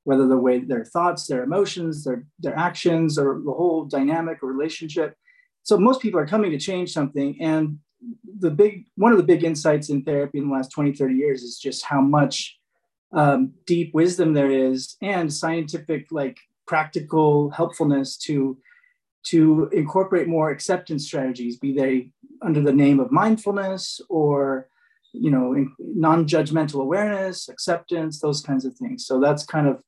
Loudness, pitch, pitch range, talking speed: -22 LUFS, 155 Hz, 140-175 Hz, 165 wpm